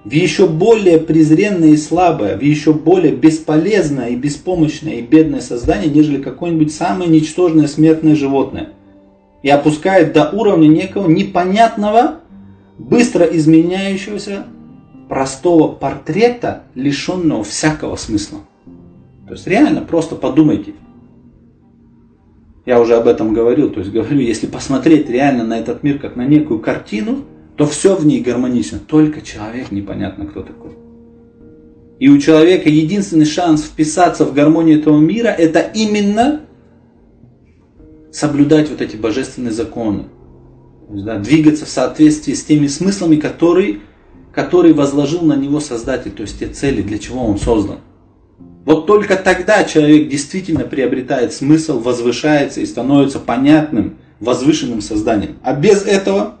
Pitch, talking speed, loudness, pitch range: 155 Hz, 130 wpm, -13 LUFS, 135-180 Hz